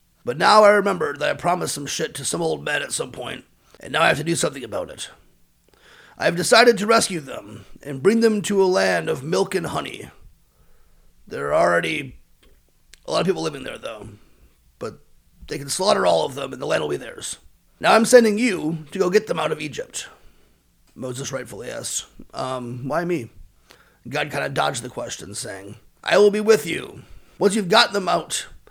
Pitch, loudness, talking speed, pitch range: 190 Hz, -20 LUFS, 205 wpm, 135-215 Hz